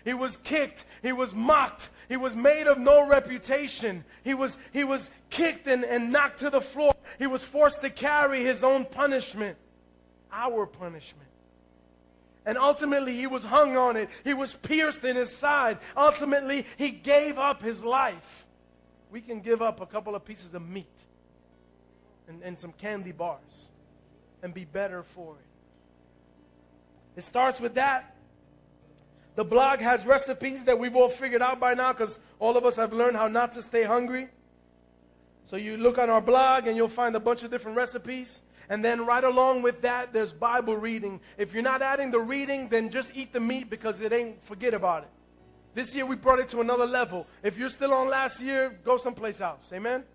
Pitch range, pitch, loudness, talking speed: 195-265 Hz, 245 Hz, -26 LUFS, 185 wpm